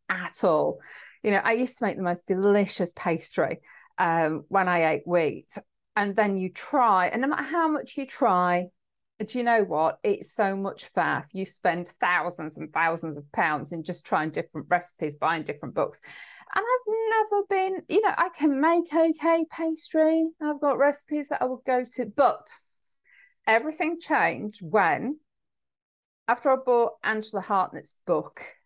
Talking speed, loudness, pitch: 170 wpm, -26 LUFS, 225 Hz